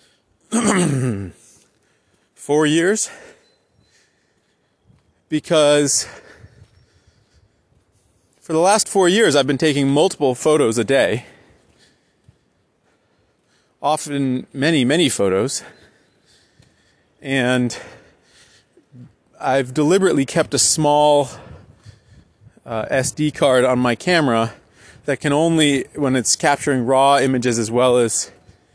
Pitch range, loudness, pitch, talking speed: 115-150 Hz, -17 LUFS, 135 Hz, 90 wpm